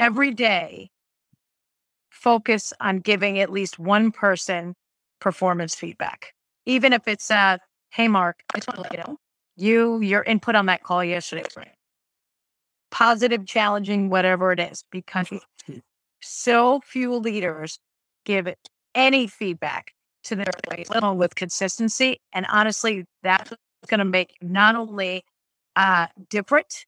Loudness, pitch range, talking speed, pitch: -21 LUFS, 185-230 Hz, 125 wpm, 205 Hz